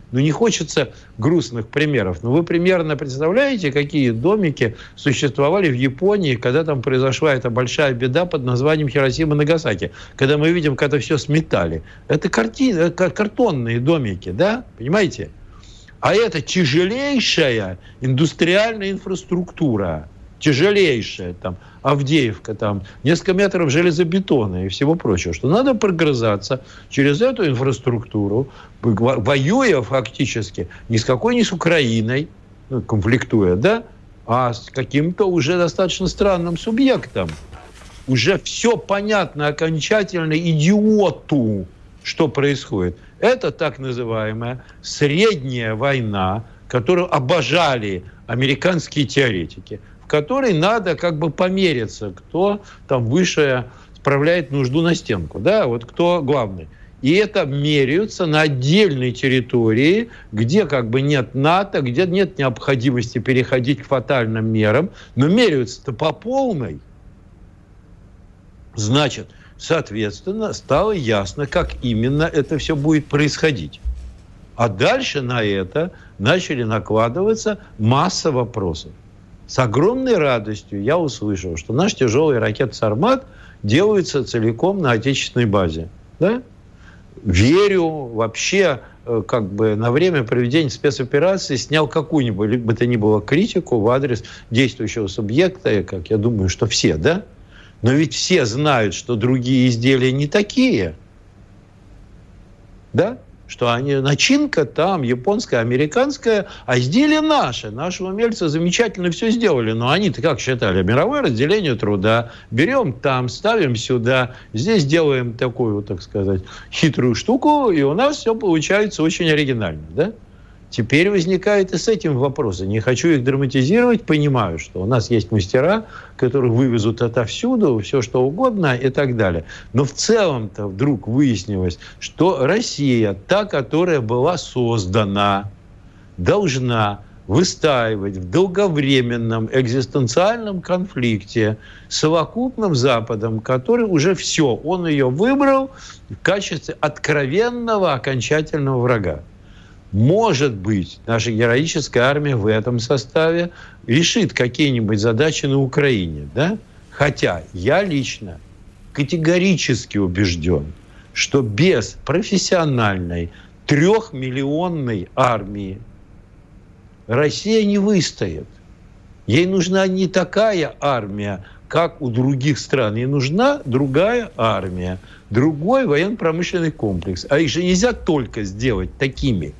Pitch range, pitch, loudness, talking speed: 105-165 Hz, 130 Hz, -18 LUFS, 115 wpm